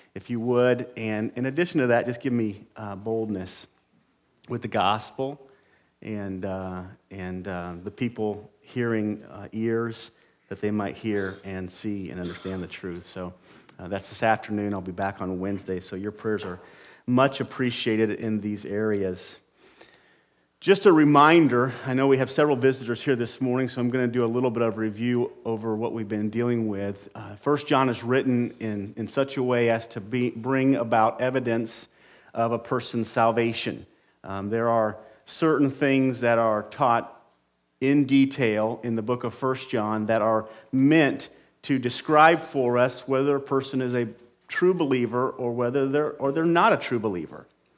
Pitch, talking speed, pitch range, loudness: 115 Hz, 175 wpm, 105-130 Hz, -25 LUFS